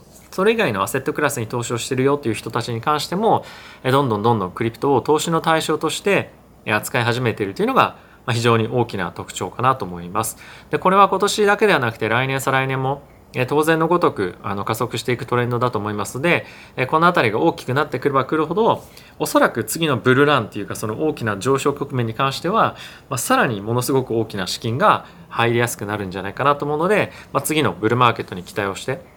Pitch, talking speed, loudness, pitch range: 130 Hz, 460 characters per minute, -19 LUFS, 110-155 Hz